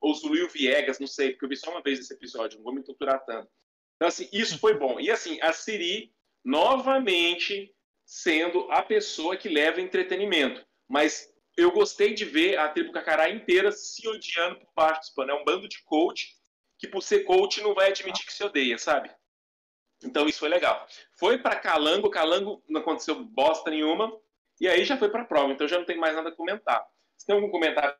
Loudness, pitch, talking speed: -26 LUFS, 180 Hz, 200 wpm